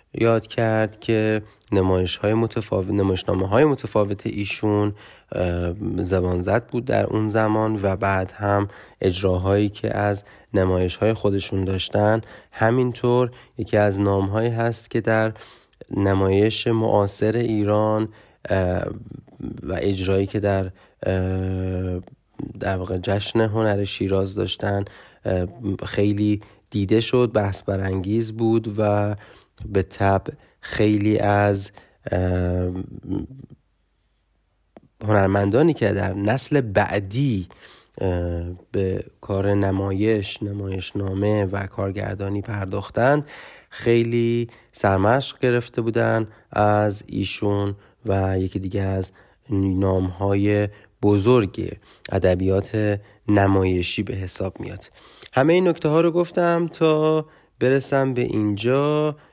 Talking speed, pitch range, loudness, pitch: 100 wpm, 95-110 Hz, -22 LUFS, 105 Hz